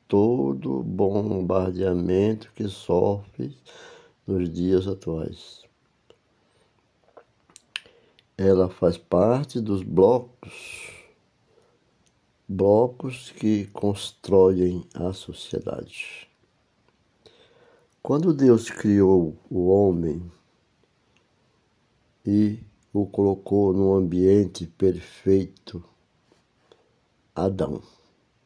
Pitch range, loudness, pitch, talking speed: 95-110 Hz, -23 LUFS, 100 Hz, 60 wpm